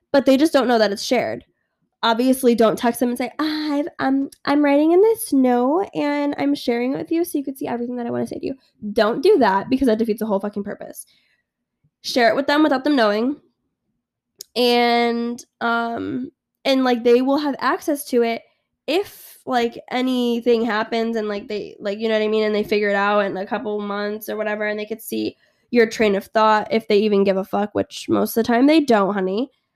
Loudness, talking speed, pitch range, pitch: -20 LUFS, 230 wpm, 210-275 Hz, 235 Hz